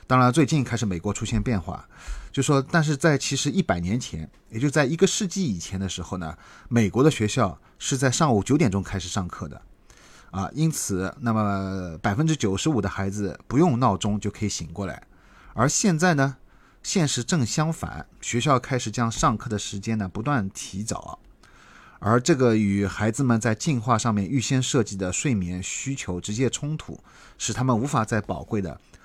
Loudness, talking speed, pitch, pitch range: -24 LUFS, 280 characters per minute, 115 Hz, 100-140 Hz